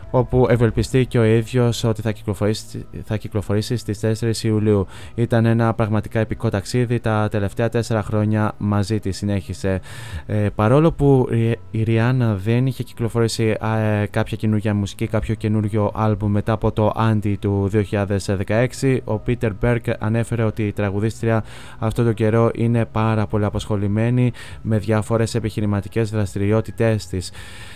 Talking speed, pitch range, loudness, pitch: 140 wpm, 105-115 Hz, -20 LUFS, 110 Hz